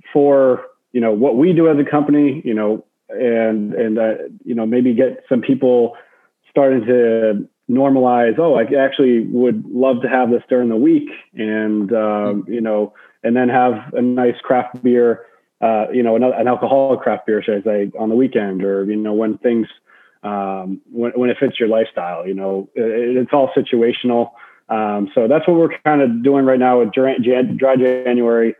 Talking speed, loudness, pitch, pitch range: 190 wpm, -16 LUFS, 120 Hz, 110-130 Hz